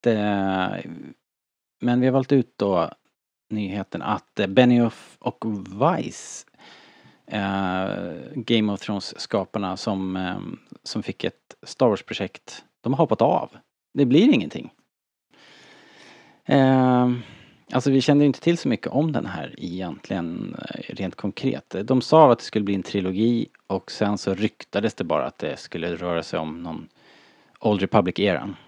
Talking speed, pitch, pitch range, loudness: 130 wpm, 105 Hz, 95-120 Hz, -23 LUFS